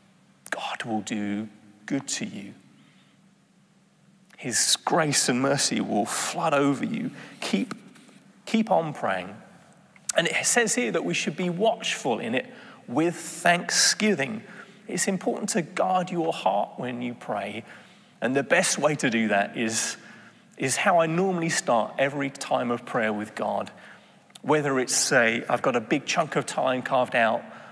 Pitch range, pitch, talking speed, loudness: 130-205 Hz, 175 Hz, 155 wpm, -25 LUFS